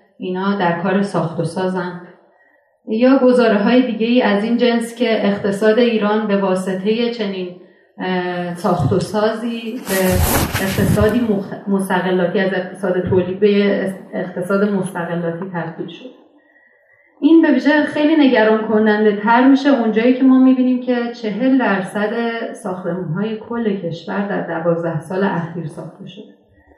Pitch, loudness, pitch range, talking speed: 205 Hz, -16 LUFS, 185-235 Hz, 130 wpm